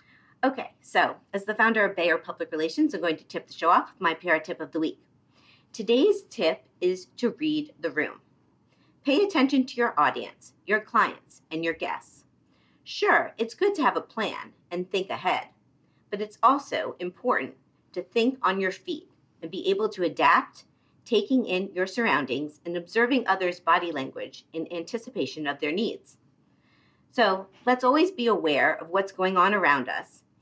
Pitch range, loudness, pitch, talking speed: 175-260 Hz, -26 LUFS, 215 Hz, 175 wpm